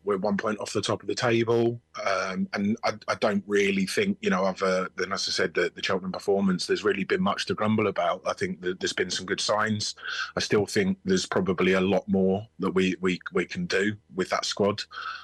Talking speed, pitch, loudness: 235 wpm, 110 Hz, -26 LUFS